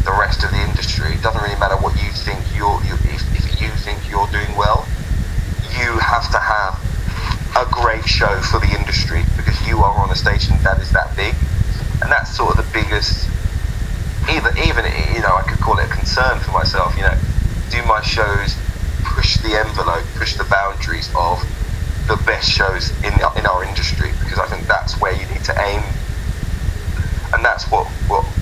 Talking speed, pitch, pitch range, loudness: 190 wpm, 95 Hz, 85-100 Hz, -18 LUFS